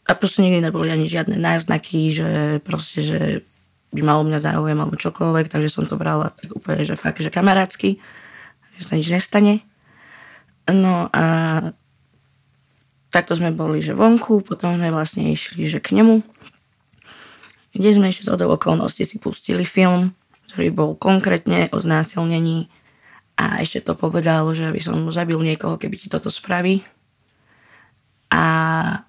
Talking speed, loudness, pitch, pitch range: 150 wpm, -19 LUFS, 165 Hz, 155-190 Hz